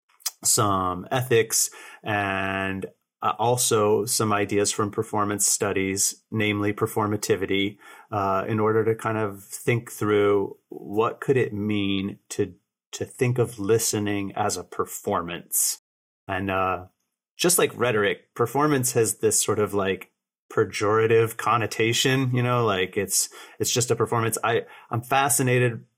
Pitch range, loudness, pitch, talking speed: 100-115 Hz, -24 LUFS, 105 Hz, 125 wpm